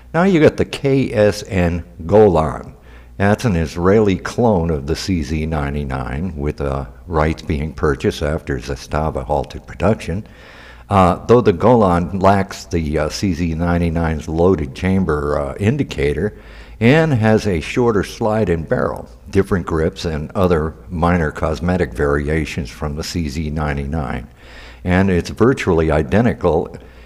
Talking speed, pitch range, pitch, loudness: 120 wpm, 75-95 Hz, 85 Hz, -17 LUFS